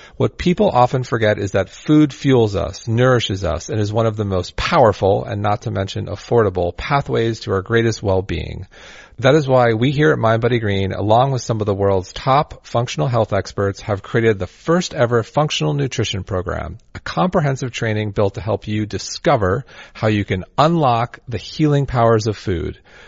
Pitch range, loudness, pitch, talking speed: 100-130 Hz, -18 LUFS, 110 Hz, 180 wpm